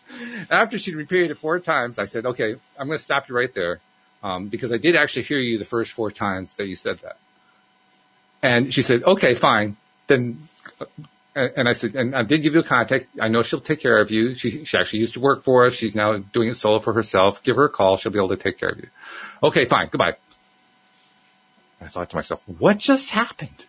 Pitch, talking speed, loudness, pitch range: 125 Hz, 235 wpm, -20 LUFS, 115-160 Hz